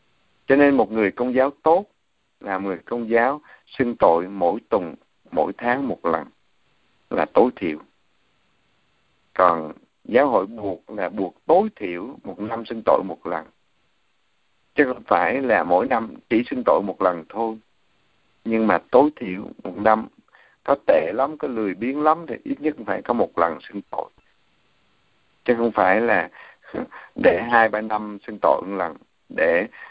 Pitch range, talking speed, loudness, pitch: 100-120 Hz, 165 wpm, -21 LUFS, 110 Hz